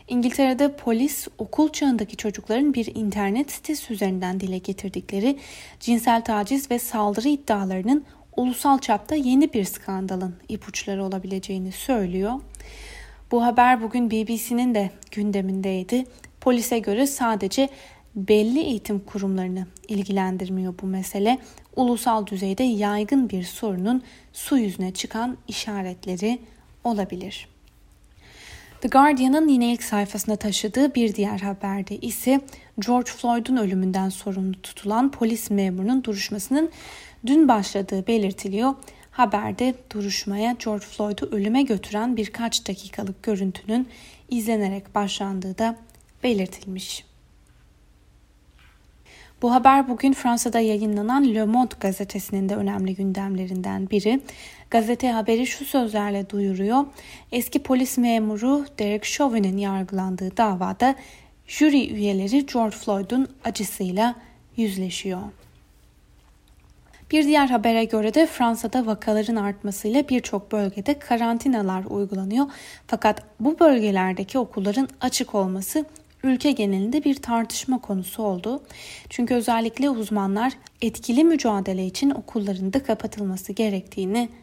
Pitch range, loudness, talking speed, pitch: 200-250 Hz, -23 LUFS, 105 wpm, 220 Hz